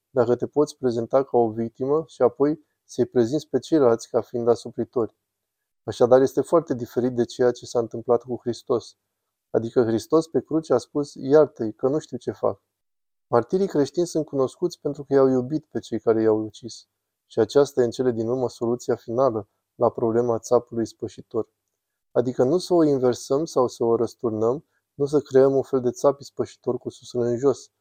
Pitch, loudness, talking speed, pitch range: 125 Hz, -23 LUFS, 185 wpm, 115-140 Hz